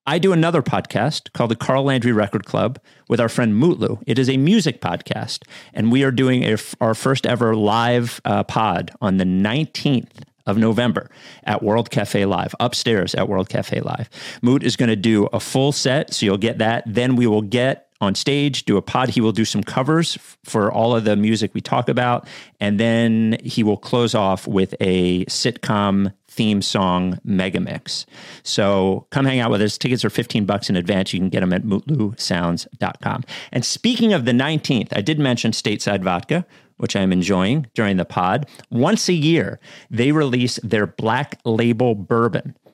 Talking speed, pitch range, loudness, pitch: 190 wpm, 105-135 Hz, -19 LUFS, 115 Hz